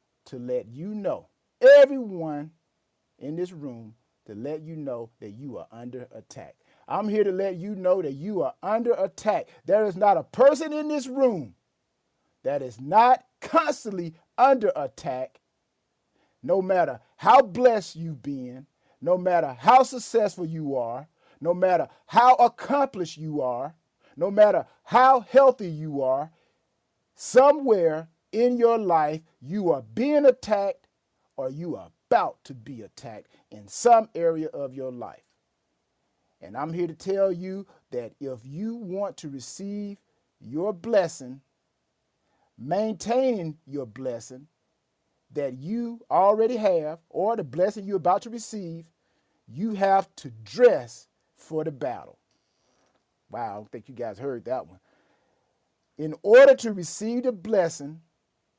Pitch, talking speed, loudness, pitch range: 185 Hz, 140 wpm, -23 LUFS, 150-225 Hz